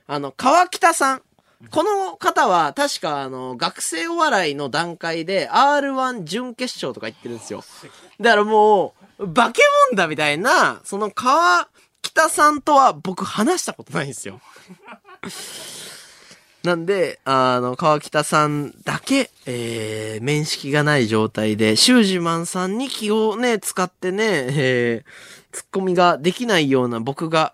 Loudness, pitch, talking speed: -19 LUFS, 175 Hz, 270 characters per minute